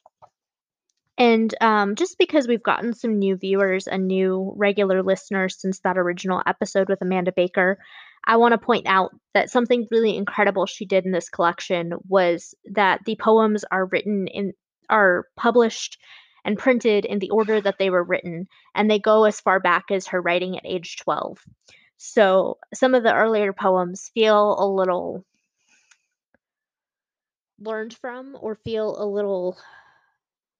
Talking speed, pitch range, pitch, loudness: 155 wpm, 185-220 Hz, 200 Hz, -21 LUFS